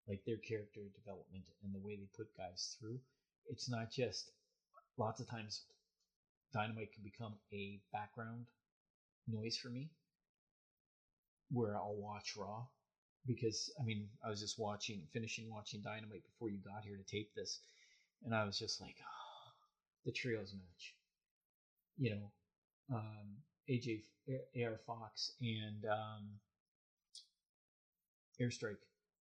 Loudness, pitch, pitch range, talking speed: -46 LUFS, 110 Hz, 105-120 Hz, 130 wpm